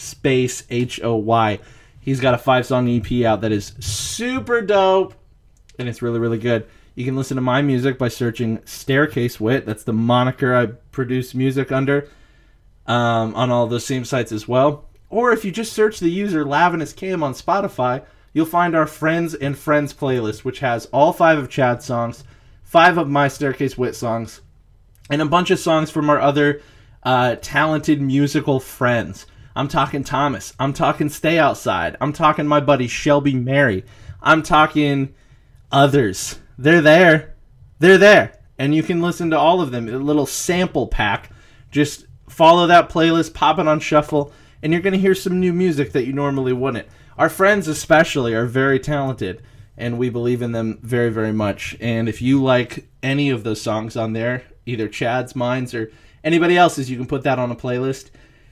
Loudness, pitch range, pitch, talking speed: -18 LUFS, 120-155 Hz, 130 Hz, 185 wpm